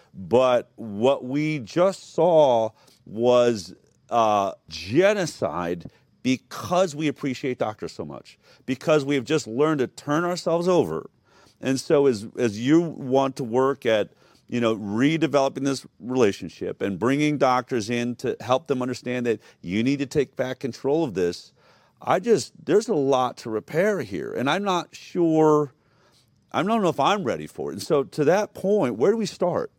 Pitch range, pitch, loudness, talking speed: 125-155 Hz, 135 Hz, -23 LUFS, 165 wpm